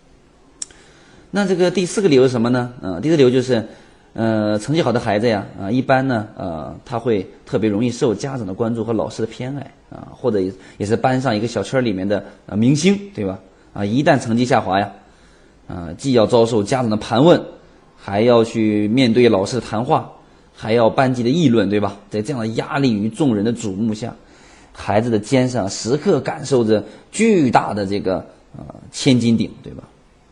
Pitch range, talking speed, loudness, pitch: 105-130 Hz, 290 characters per minute, -18 LUFS, 115 Hz